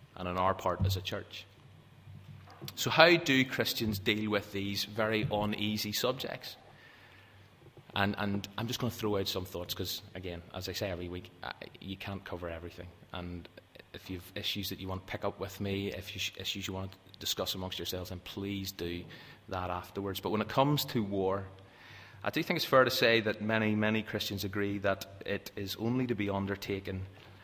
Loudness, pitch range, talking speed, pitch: -33 LUFS, 95-105 Hz, 200 wpm, 100 Hz